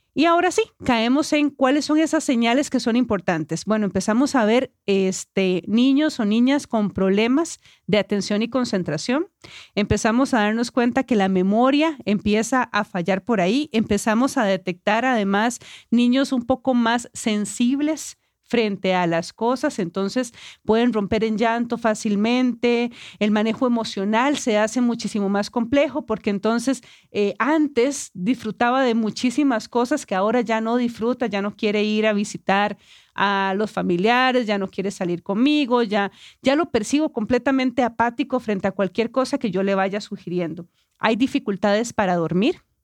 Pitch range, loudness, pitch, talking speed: 205-255 Hz, -21 LUFS, 230 Hz, 155 wpm